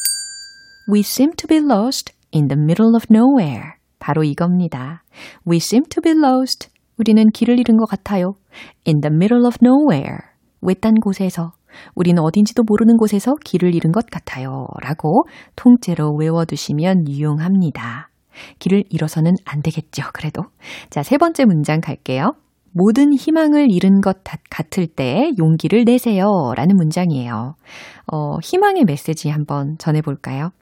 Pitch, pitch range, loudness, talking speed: 185 Hz, 155-240 Hz, -16 LUFS, 365 characters per minute